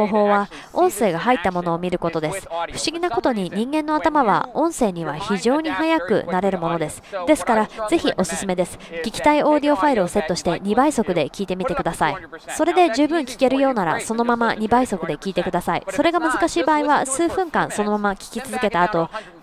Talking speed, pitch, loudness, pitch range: 425 characters per minute, 215 Hz, -20 LUFS, 180-295 Hz